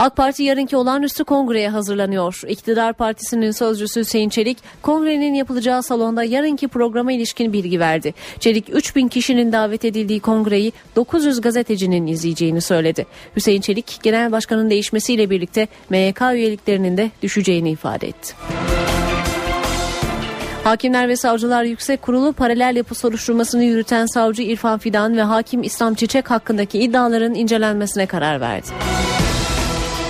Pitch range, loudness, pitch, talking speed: 205-245 Hz, -18 LUFS, 225 Hz, 125 wpm